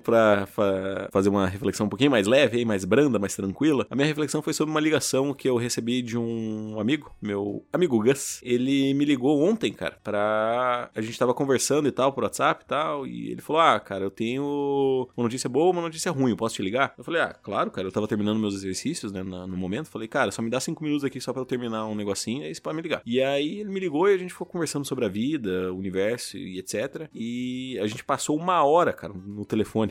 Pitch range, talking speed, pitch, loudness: 105-140 Hz, 235 wpm, 120 Hz, -25 LUFS